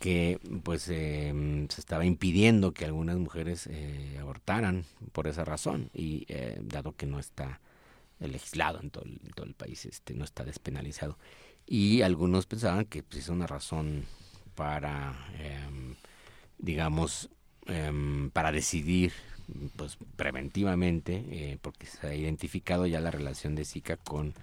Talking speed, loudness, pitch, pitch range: 145 wpm, -33 LUFS, 80 Hz, 75-90 Hz